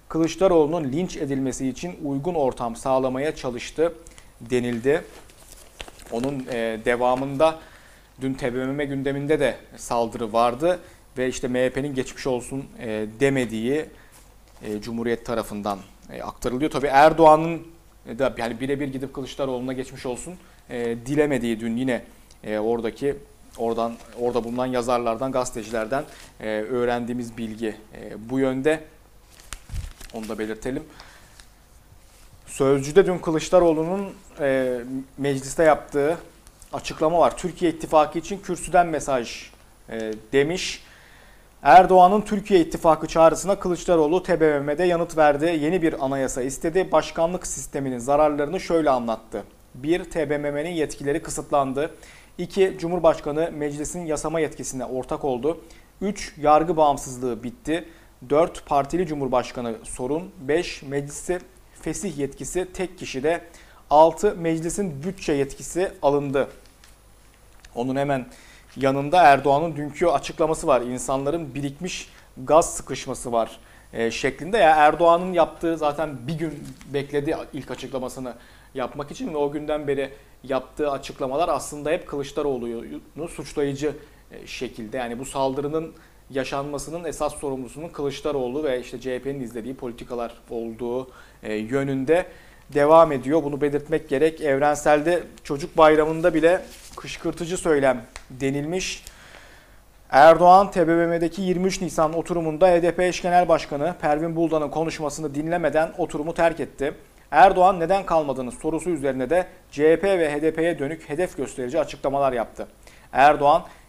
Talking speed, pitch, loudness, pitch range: 105 wpm, 145 Hz, -23 LUFS, 125-165 Hz